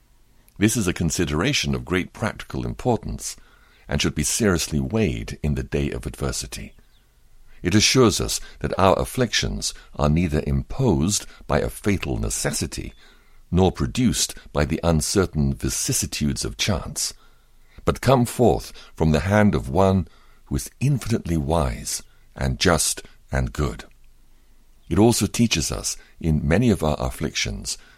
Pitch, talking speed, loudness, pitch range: 80 Hz, 135 wpm, -22 LUFS, 70-100 Hz